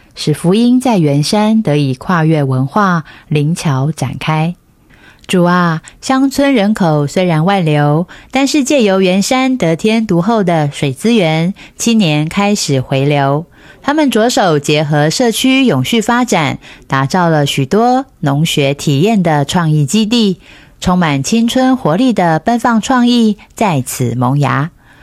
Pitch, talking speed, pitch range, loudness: 175 Hz, 210 characters per minute, 145-225 Hz, -12 LUFS